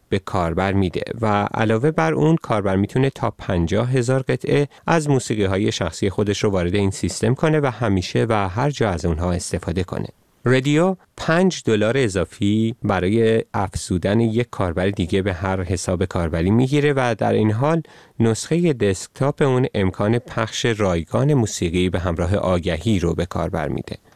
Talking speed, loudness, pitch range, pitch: 160 wpm, -20 LUFS, 95-130 Hz, 110 Hz